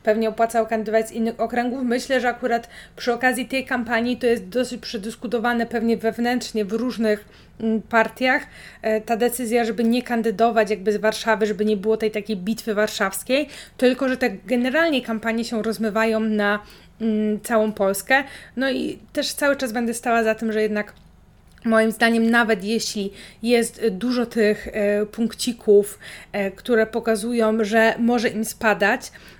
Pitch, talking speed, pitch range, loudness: 225 Hz, 145 wpm, 220-240 Hz, -22 LUFS